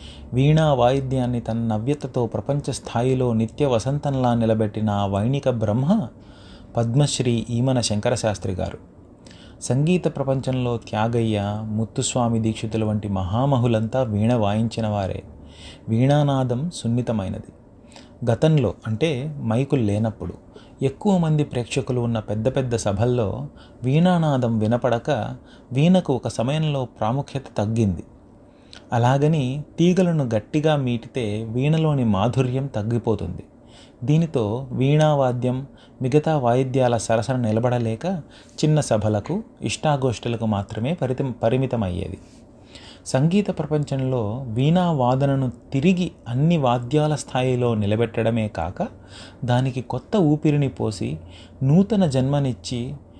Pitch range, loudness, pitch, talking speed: 110-140 Hz, -22 LUFS, 125 Hz, 90 wpm